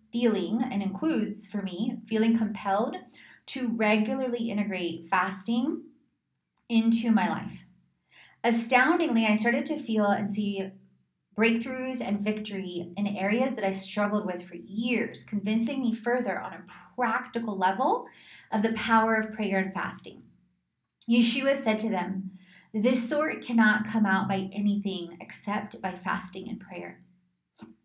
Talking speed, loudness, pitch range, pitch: 135 wpm, -27 LUFS, 190-235 Hz, 215 Hz